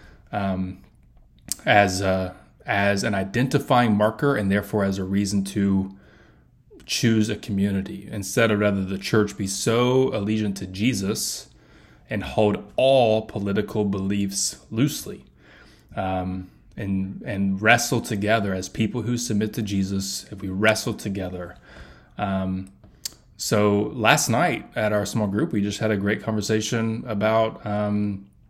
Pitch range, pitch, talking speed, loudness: 95-110 Hz, 100 Hz, 135 wpm, -23 LUFS